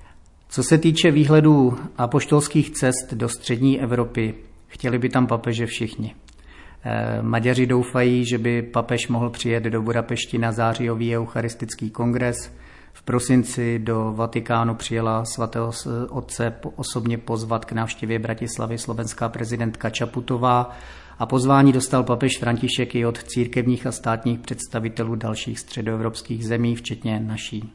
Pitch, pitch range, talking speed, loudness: 120 Hz, 115-125 Hz, 125 wpm, -22 LUFS